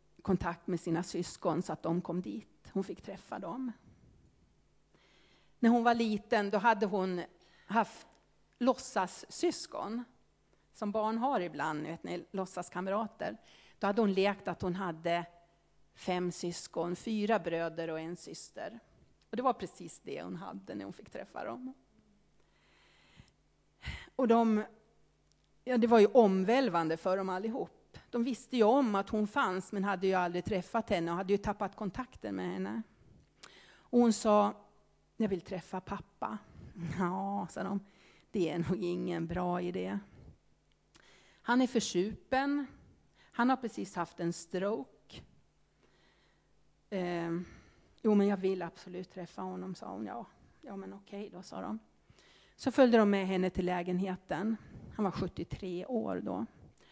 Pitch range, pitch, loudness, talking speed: 175-220 Hz, 190 Hz, -34 LUFS, 145 wpm